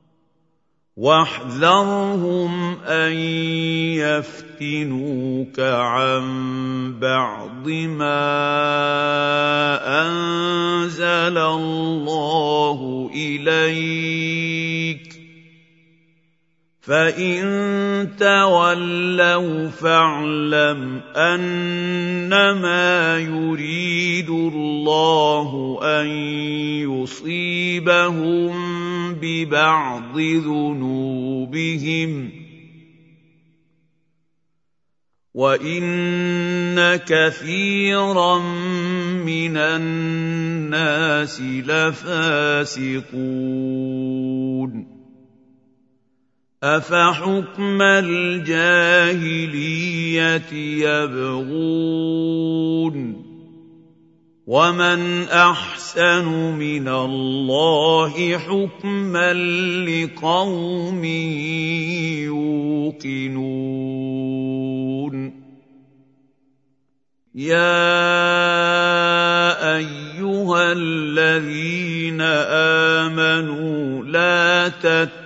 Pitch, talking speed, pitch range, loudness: 160 Hz, 30 wpm, 145-175 Hz, -19 LUFS